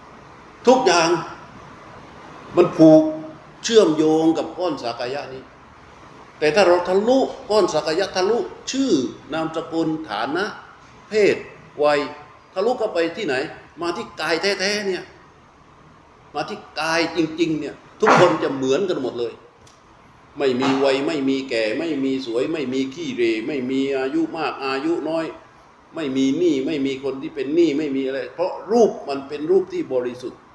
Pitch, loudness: 160 Hz, -20 LUFS